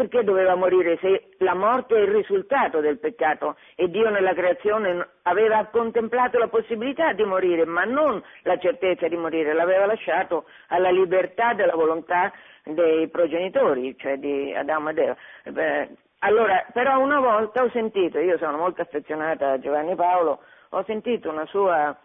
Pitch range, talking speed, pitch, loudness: 165-230 Hz, 155 wpm, 185 Hz, -22 LUFS